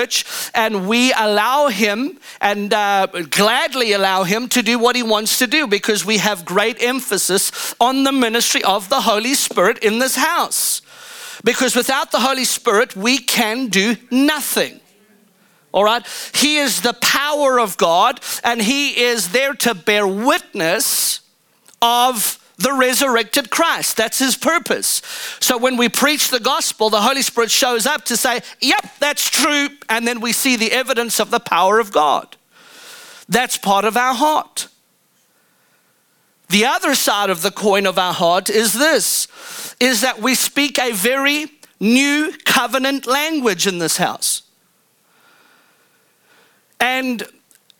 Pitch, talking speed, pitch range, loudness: 245 Hz, 150 wpm, 215-275 Hz, -16 LUFS